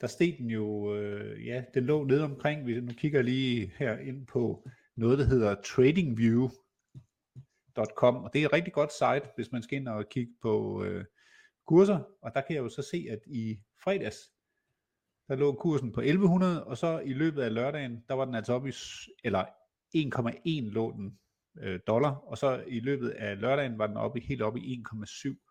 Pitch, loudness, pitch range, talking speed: 130 Hz, -31 LUFS, 115-145 Hz, 200 wpm